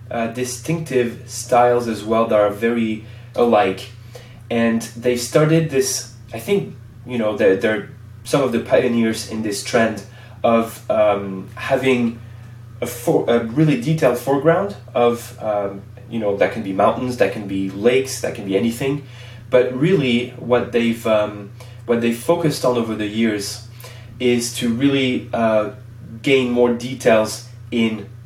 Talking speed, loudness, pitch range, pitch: 150 wpm, -19 LUFS, 115-125 Hz, 120 Hz